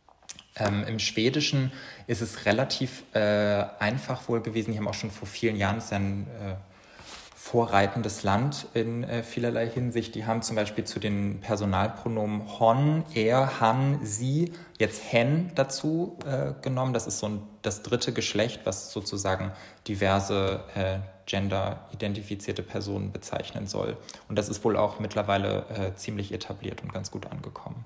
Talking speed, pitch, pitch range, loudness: 150 wpm, 110 Hz, 100-120 Hz, -29 LUFS